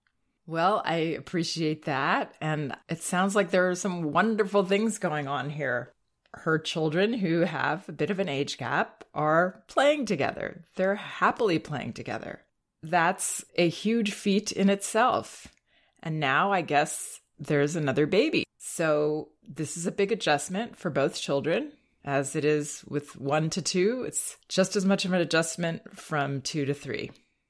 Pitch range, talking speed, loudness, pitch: 150-195 Hz, 160 wpm, -27 LUFS, 165 Hz